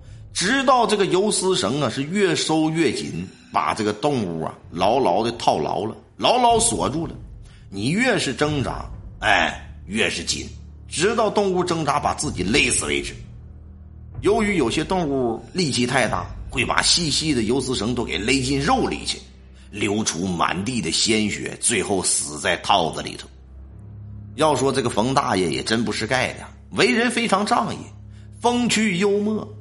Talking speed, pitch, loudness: 235 characters per minute, 135 Hz, -21 LUFS